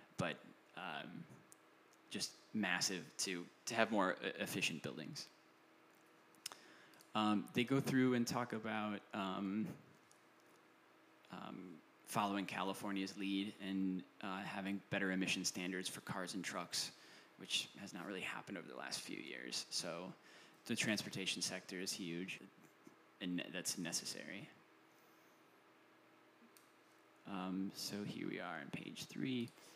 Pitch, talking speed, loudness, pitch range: 100 Hz, 120 wpm, -43 LUFS, 95-105 Hz